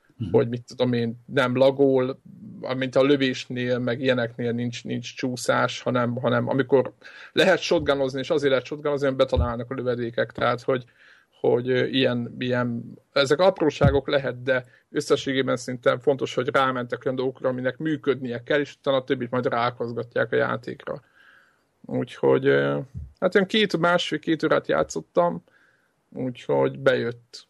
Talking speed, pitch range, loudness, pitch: 135 wpm, 120-140 Hz, -24 LUFS, 130 Hz